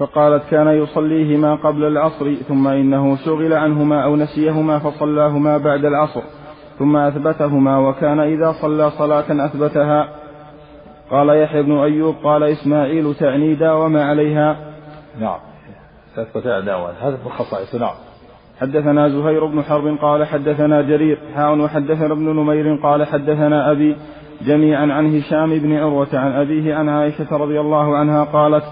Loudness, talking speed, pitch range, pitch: -16 LUFS, 125 wpm, 145-150 Hz, 150 Hz